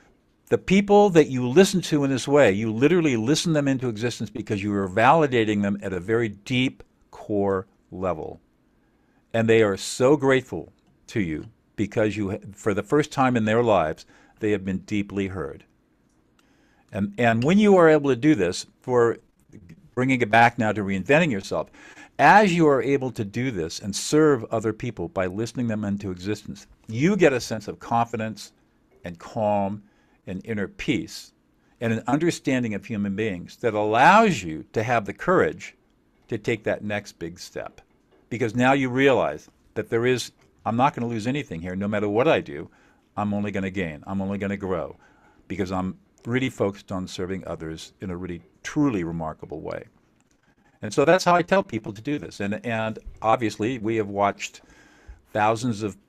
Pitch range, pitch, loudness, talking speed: 100-130 Hz, 110 Hz, -23 LUFS, 180 wpm